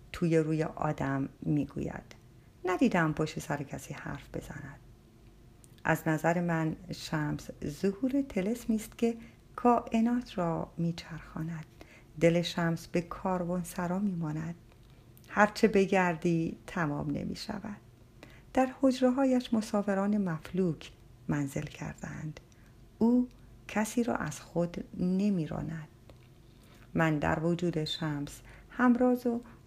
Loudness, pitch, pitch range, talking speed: -31 LUFS, 170 Hz, 150-210 Hz, 100 wpm